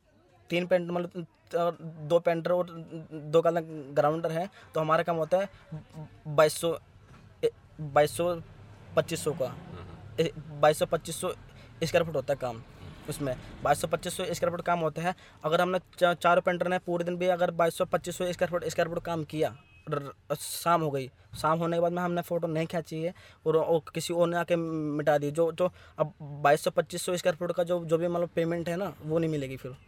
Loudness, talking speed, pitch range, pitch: -29 LUFS, 210 wpm, 150-175 Hz, 165 Hz